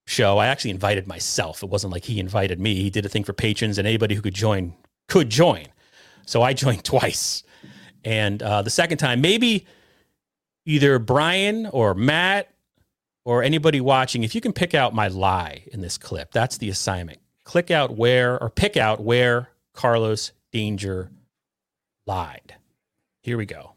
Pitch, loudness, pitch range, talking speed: 115 Hz, -21 LUFS, 100-130 Hz, 170 wpm